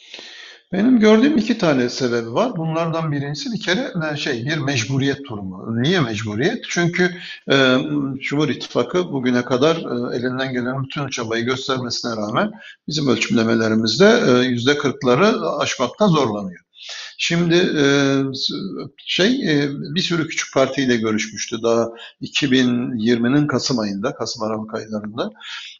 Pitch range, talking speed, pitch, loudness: 120-165 Hz, 120 wpm, 135 Hz, -19 LUFS